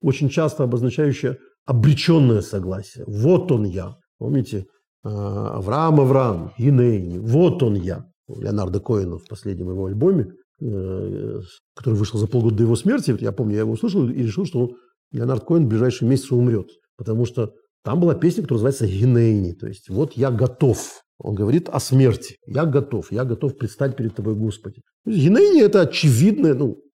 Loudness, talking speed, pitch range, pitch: -20 LUFS, 165 wpm, 105-140 Hz, 120 Hz